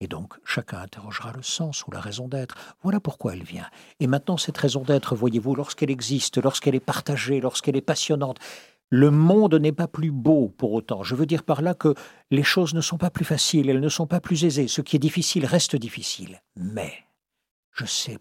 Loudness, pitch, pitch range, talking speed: -23 LUFS, 145 Hz, 135-165 Hz, 210 wpm